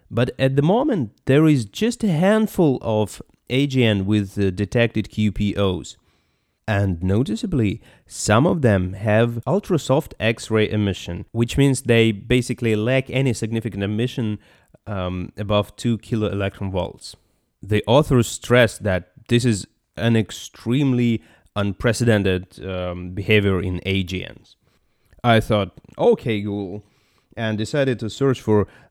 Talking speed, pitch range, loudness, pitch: 125 wpm, 100-125 Hz, -21 LUFS, 110 Hz